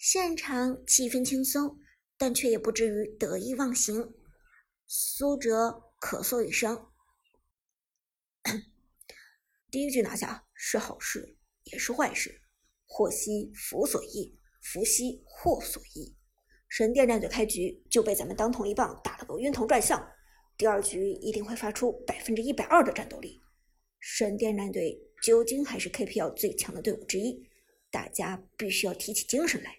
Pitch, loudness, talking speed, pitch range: 230 Hz, -29 LUFS, 225 characters per minute, 215-275 Hz